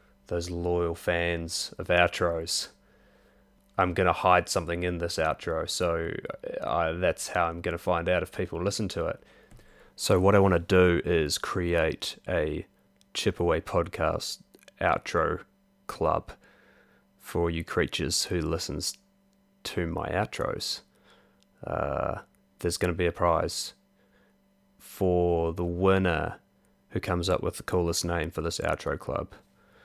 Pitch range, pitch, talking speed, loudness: 85-95 Hz, 90 Hz, 135 wpm, -28 LUFS